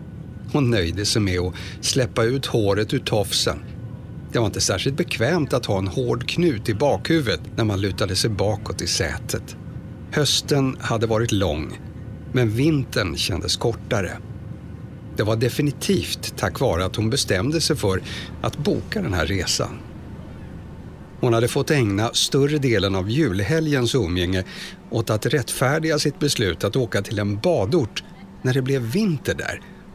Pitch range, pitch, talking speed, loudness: 100-135 Hz, 115 Hz, 150 wpm, -22 LUFS